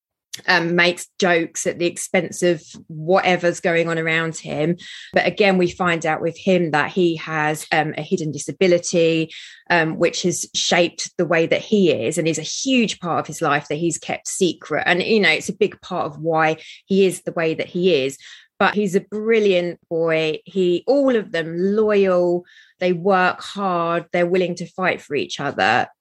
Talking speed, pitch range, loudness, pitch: 190 wpm, 165-185 Hz, -19 LUFS, 175 Hz